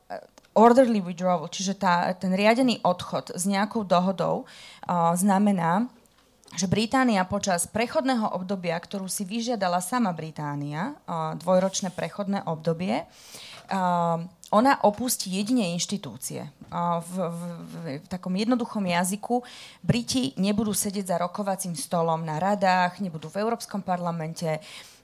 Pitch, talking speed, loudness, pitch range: 190 Hz, 125 wpm, -26 LUFS, 170-210 Hz